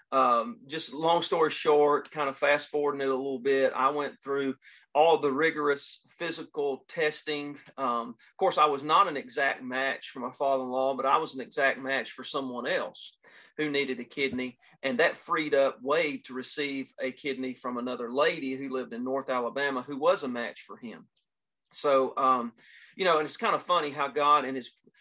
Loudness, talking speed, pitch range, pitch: -28 LUFS, 200 wpm, 130-145 Hz, 135 Hz